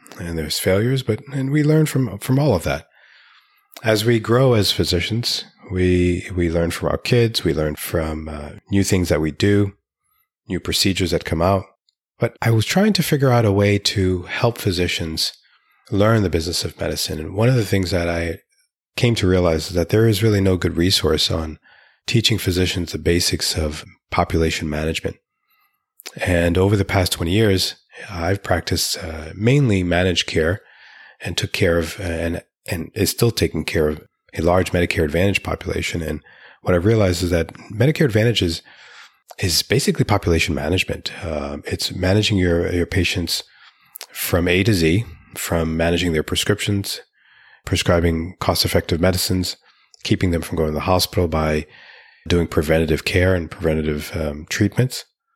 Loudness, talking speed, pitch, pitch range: -19 LUFS, 165 wpm, 90 Hz, 85-105 Hz